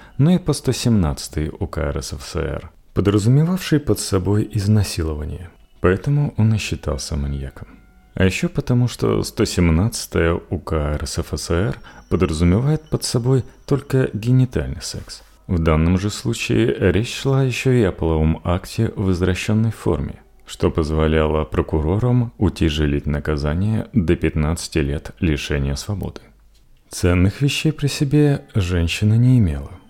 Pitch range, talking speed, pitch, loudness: 80-120 Hz, 120 wpm, 95 Hz, -20 LUFS